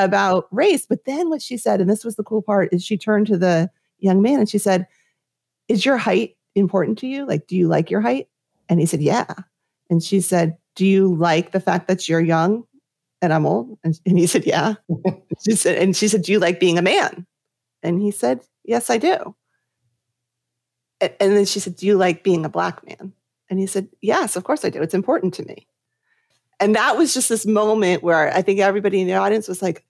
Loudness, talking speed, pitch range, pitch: -19 LUFS, 230 wpm, 170-210 Hz, 190 Hz